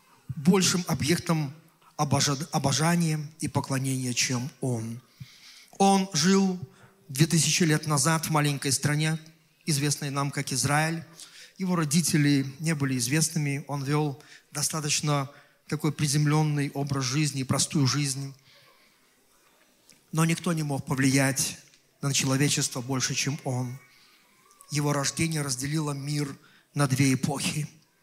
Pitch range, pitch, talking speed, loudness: 140-160 Hz, 150 Hz, 110 wpm, -26 LUFS